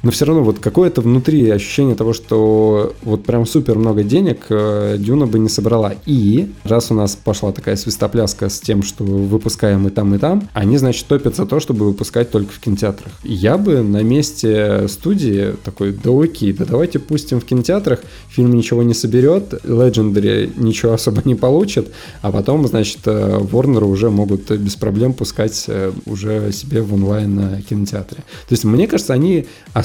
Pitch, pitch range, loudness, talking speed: 110 Hz, 105-125 Hz, -15 LUFS, 170 wpm